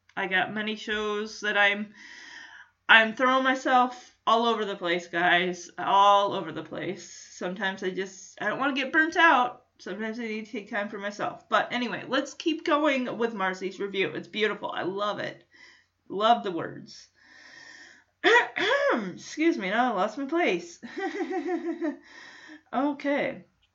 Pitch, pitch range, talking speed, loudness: 225 Hz, 200-280 Hz, 150 wpm, -26 LUFS